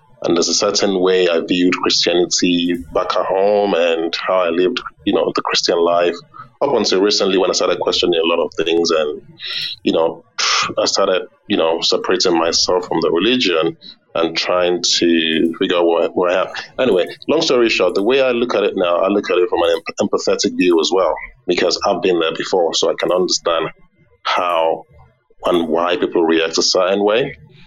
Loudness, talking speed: -16 LUFS, 195 wpm